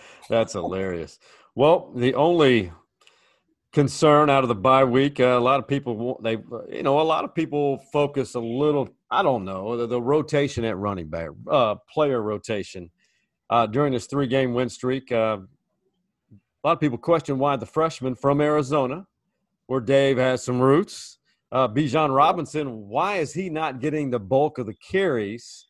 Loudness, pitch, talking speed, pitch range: -23 LUFS, 135 Hz, 175 wpm, 120-150 Hz